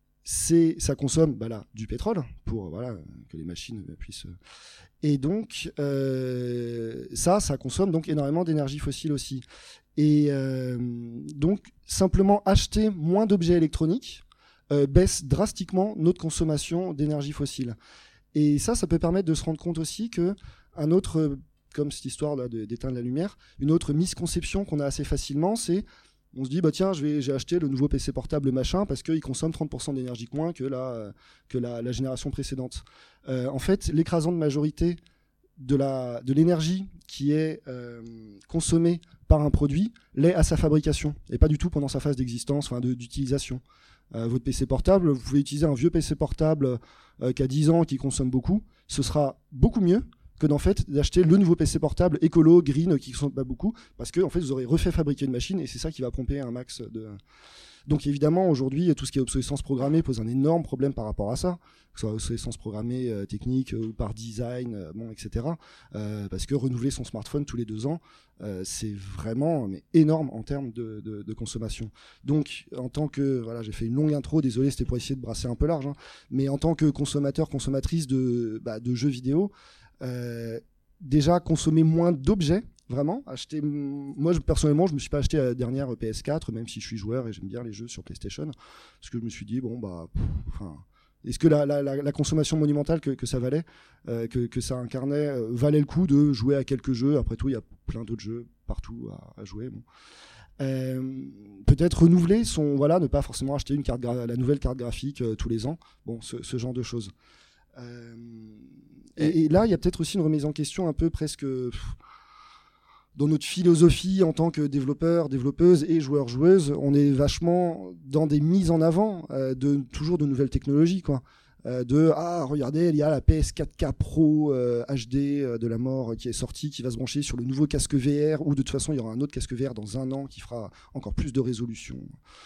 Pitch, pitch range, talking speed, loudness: 140 Hz, 125-160 Hz, 205 wpm, -26 LUFS